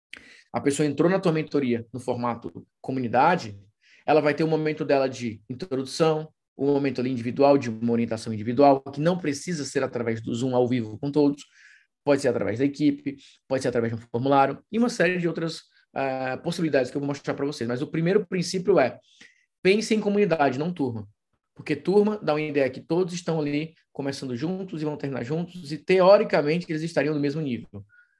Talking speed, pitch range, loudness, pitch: 195 wpm, 130-165 Hz, -25 LUFS, 145 Hz